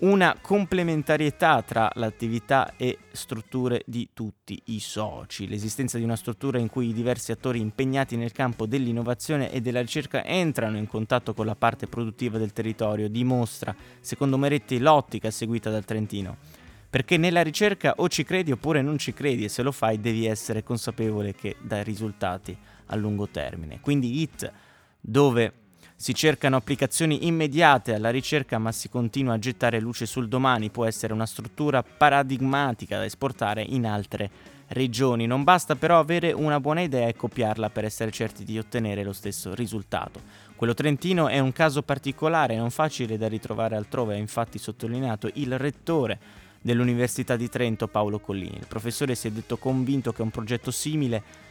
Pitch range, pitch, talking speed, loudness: 110-135 Hz, 120 Hz, 165 wpm, -26 LUFS